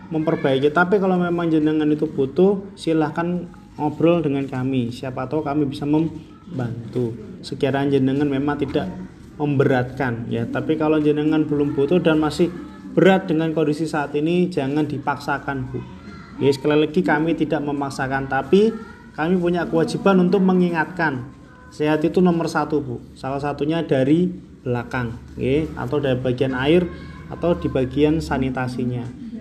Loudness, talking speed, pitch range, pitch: -21 LUFS, 135 wpm, 140-165 Hz, 150 Hz